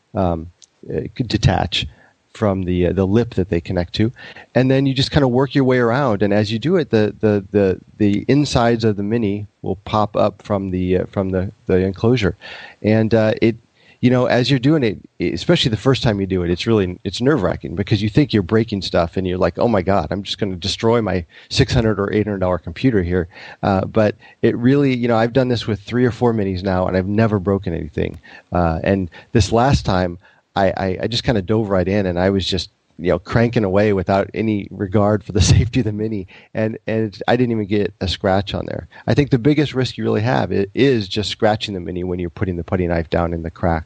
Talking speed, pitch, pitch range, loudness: 240 wpm, 105 Hz, 95-115 Hz, -18 LUFS